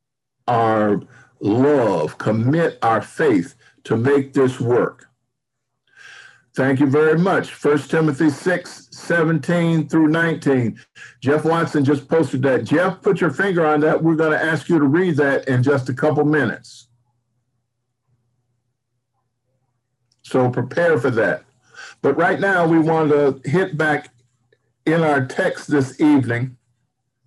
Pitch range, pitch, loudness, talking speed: 125-160 Hz, 140 Hz, -18 LUFS, 130 wpm